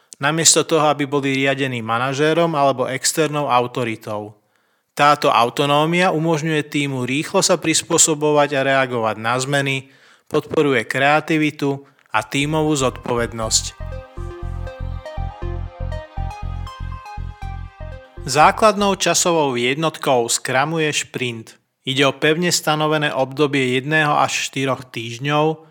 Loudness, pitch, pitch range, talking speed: -18 LUFS, 135 Hz, 110-155 Hz, 90 wpm